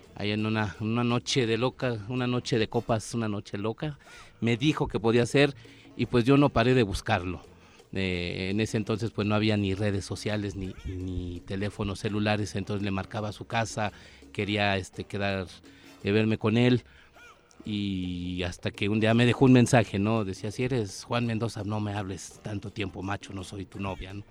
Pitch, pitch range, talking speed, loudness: 105 Hz, 95-115 Hz, 195 wpm, -28 LUFS